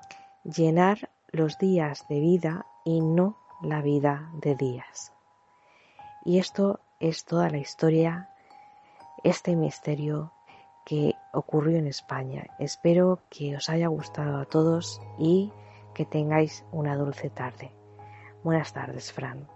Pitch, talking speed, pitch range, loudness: 155 Hz, 120 wpm, 145-170 Hz, -27 LUFS